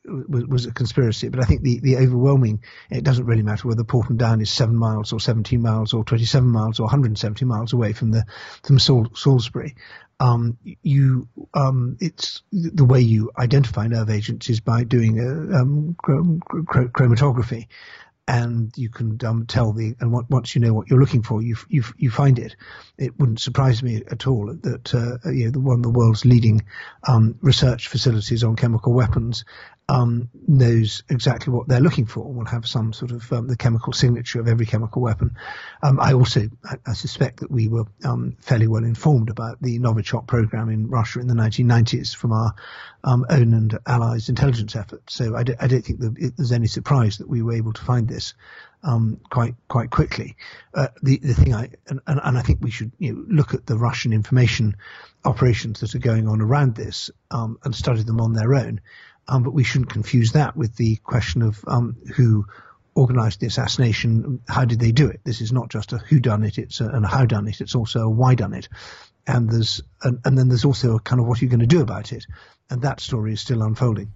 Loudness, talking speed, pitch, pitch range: -20 LUFS, 215 wpm, 120 Hz, 115-130 Hz